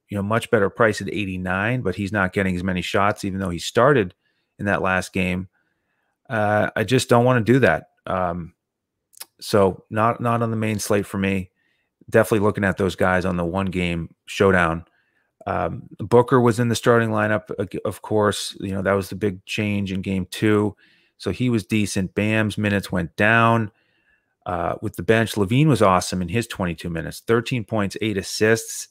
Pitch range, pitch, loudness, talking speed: 95-110 Hz, 100 Hz, -21 LUFS, 195 wpm